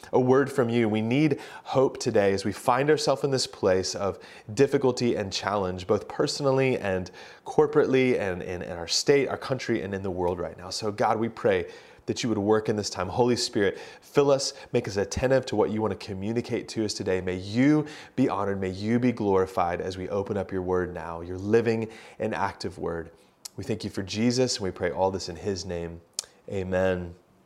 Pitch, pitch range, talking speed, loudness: 110 Hz, 95-130 Hz, 210 wpm, -26 LUFS